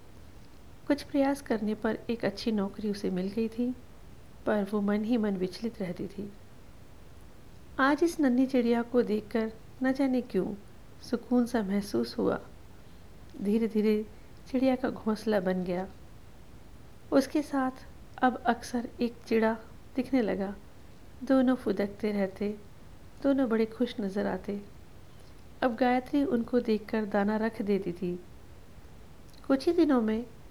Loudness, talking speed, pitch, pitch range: -30 LUFS, 130 wpm, 225 Hz, 205-255 Hz